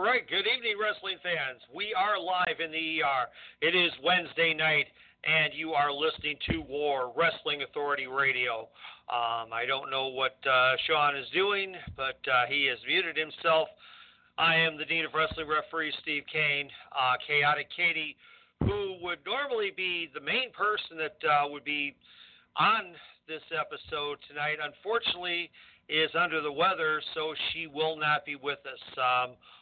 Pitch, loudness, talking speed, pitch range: 155 Hz, -29 LUFS, 160 wpm, 145-175 Hz